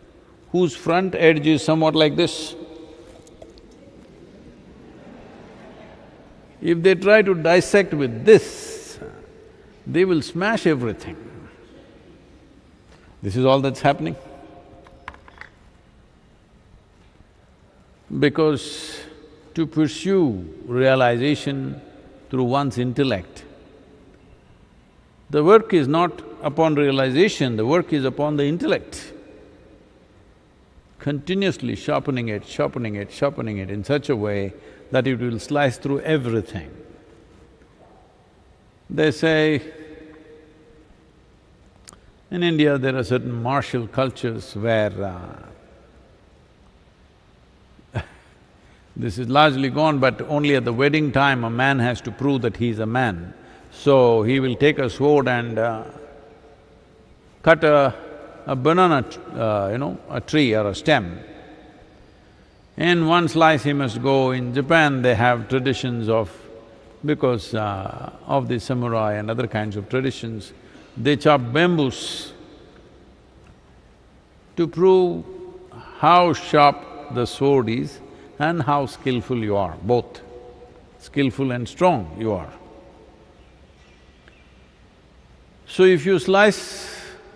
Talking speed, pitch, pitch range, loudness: 110 wpm, 135 Hz, 110-155 Hz, -20 LUFS